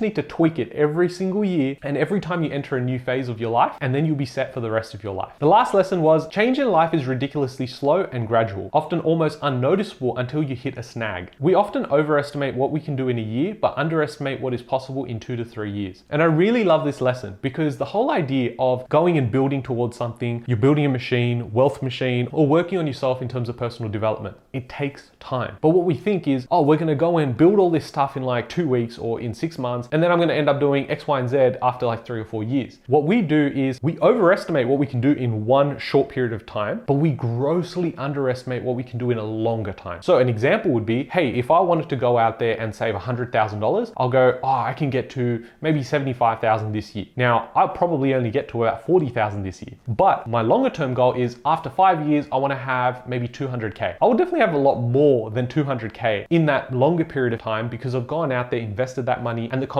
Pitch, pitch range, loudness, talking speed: 130 Hz, 120-150 Hz, -21 LUFS, 250 wpm